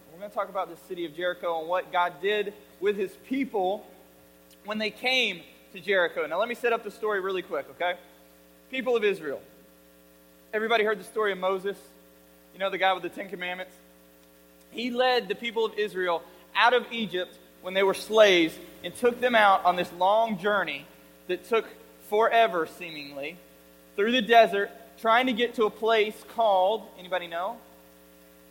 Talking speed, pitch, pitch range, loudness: 180 wpm, 190 Hz, 140-220 Hz, -26 LUFS